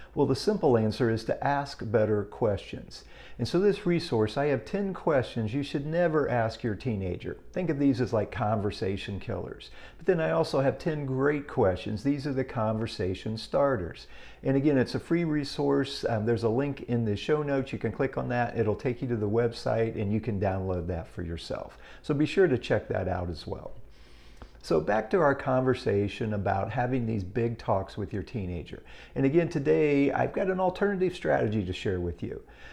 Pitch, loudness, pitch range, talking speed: 125 Hz, -29 LUFS, 105-145 Hz, 200 wpm